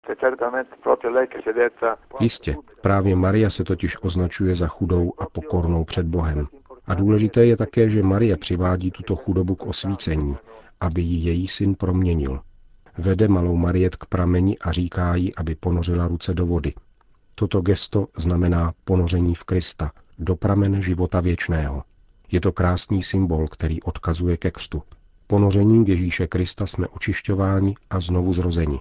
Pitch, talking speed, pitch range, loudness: 90 Hz, 140 wpm, 85-100 Hz, -22 LUFS